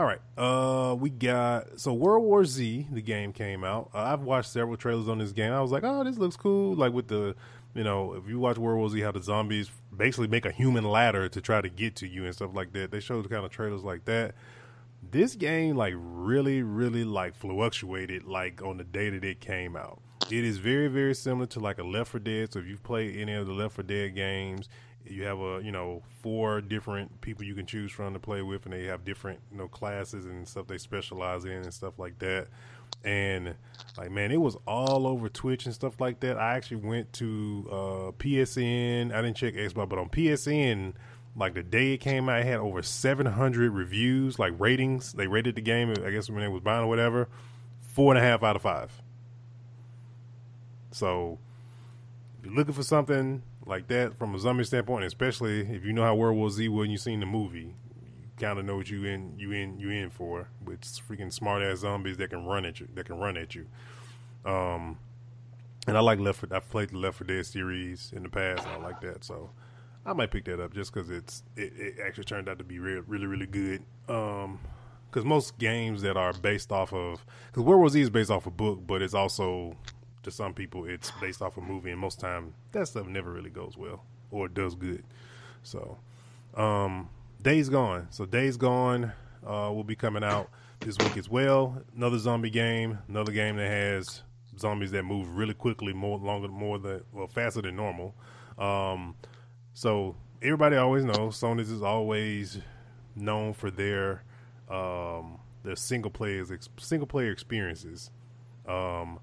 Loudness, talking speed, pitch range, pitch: -30 LUFS, 205 wpm, 100-120 Hz, 110 Hz